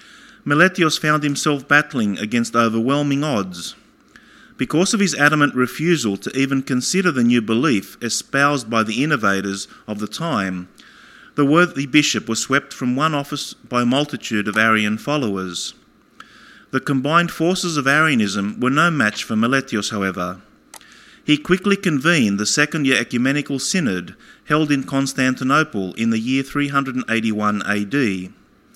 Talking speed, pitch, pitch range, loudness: 140 wpm, 130 Hz, 110-145 Hz, -18 LUFS